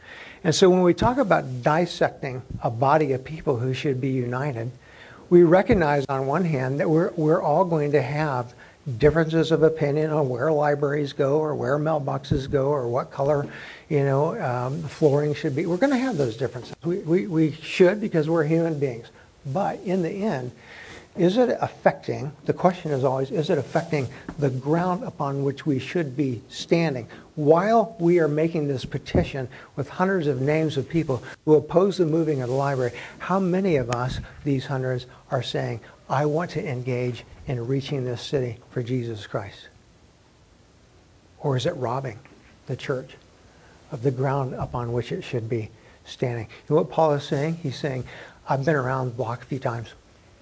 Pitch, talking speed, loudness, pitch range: 145 Hz, 180 wpm, -24 LUFS, 130-160 Hz